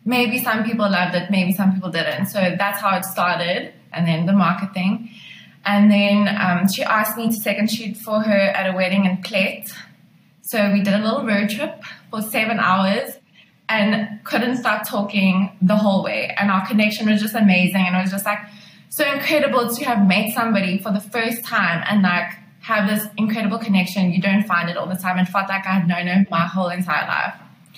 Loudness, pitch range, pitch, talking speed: -19 LUFS, 185-215 Hz, 200 Hz, 205 wpm